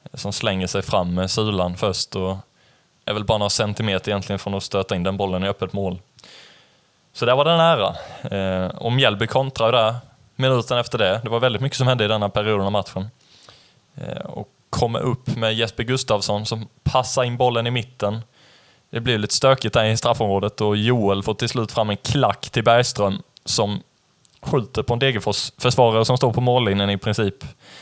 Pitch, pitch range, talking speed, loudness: 110 Hz, 100-125 Hz, 190 wpm, -20 LUFS